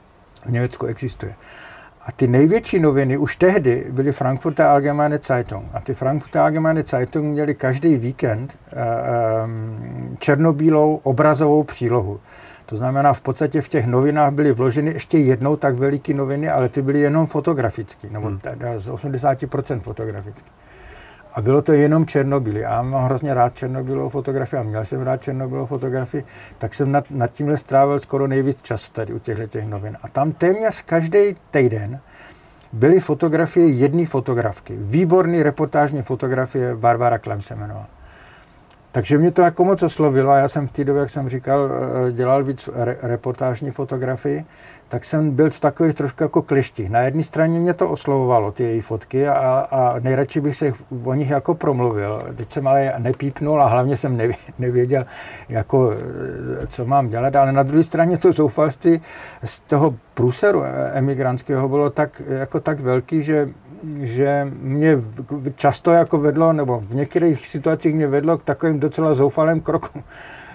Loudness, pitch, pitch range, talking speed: -19 LUFS, 140 Hz, 125-150 Hz, 155 wpm